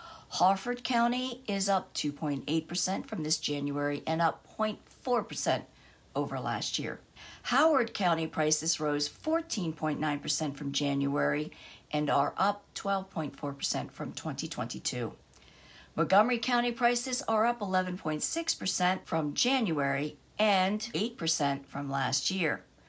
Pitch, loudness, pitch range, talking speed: 165 Hz, -30 LUFS, 145-215 Hz, 105 wpm